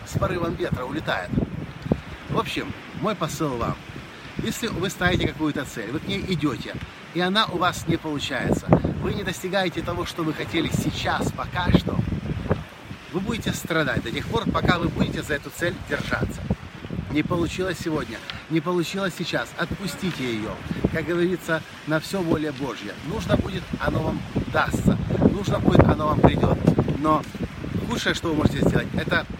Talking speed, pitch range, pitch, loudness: 160 wpm, 150-180 Hz, 165 Hz, -25 LUFS